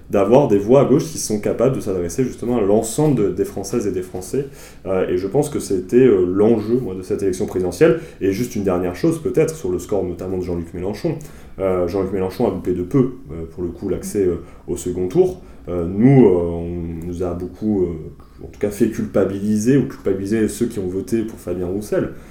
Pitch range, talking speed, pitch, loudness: 90-120 Hz, 225 wpm, 95 Hz, -19 LUFS